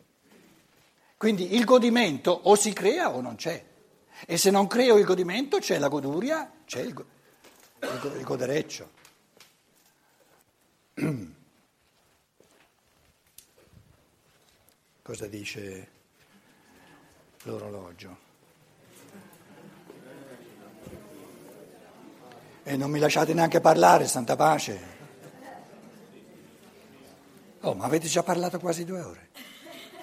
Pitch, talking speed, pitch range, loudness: 175 Hz, 90 wpm, 140-220 Hz, -25 LUFS